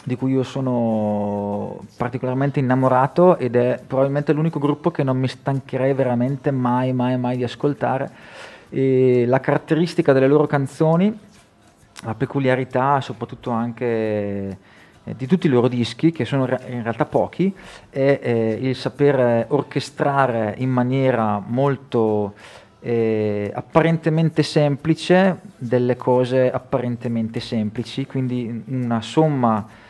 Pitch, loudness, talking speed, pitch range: 130 Hz, -20 LUFS, 115 wpm, 120-140 Hz